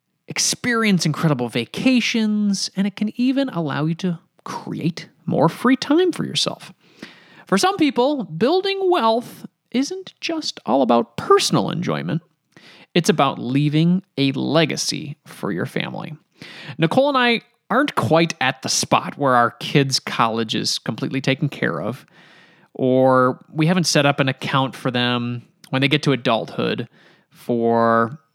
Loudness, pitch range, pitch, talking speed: -20 LUFS, 140-220 Hz, 165 Hz, 140 wpm